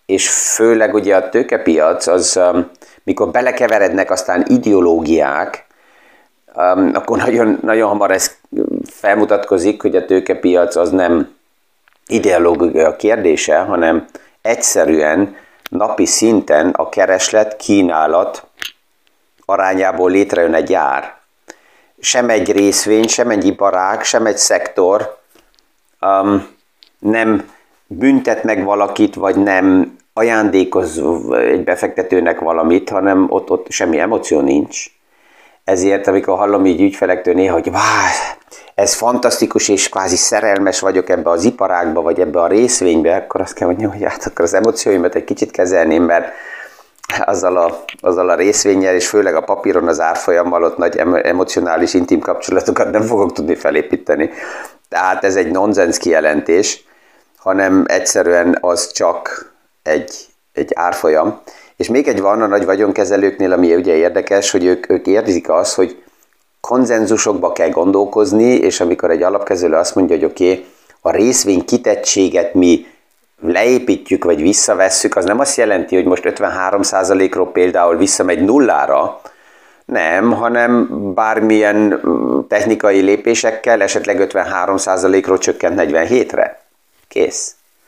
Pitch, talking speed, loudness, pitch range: 100 Hz, 125 wpm, -13 LUFS, 95-105 Hz